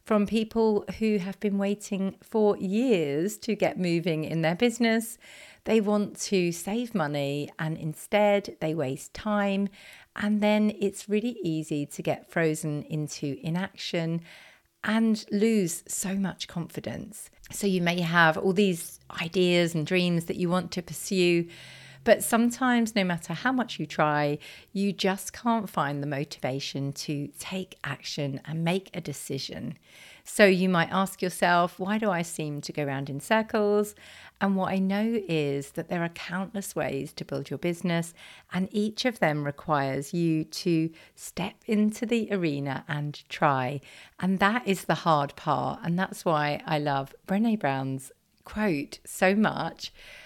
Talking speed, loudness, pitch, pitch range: 155 wpm, -27 LUFS, 180 Hz, 155-205 Hz